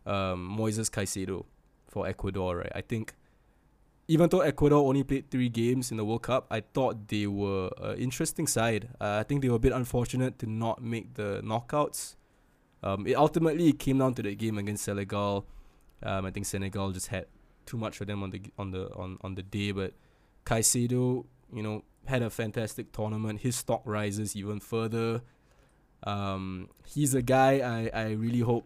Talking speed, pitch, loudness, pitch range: 185 wpm, 110 Hz, -30 LUFS, 100-125 Hz